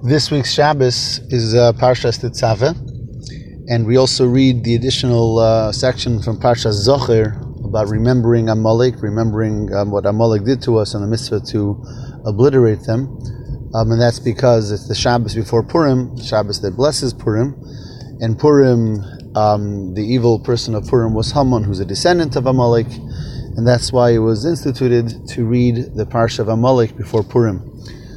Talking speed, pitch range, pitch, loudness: 160 wpm, 110-130 Hz, 120 Hz, -15 LUFS